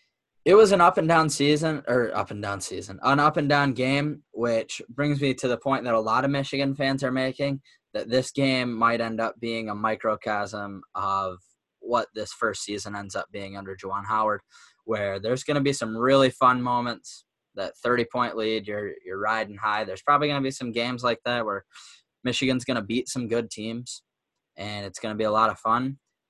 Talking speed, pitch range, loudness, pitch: 200 wpm, 110-135 Hz, -25 LUFS, 120 Hz